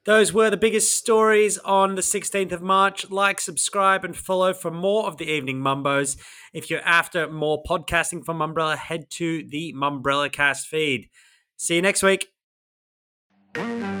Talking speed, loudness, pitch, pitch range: 165 wpm, -22 LUFS, 175 Hz, 155-195 Hz